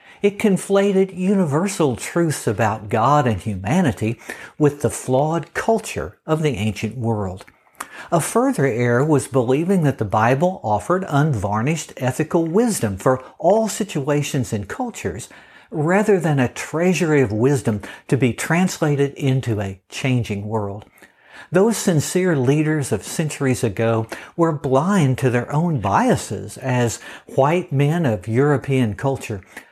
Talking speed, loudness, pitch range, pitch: 130 wpm, -20 LUFS, 115-170 Hz, 140 Hz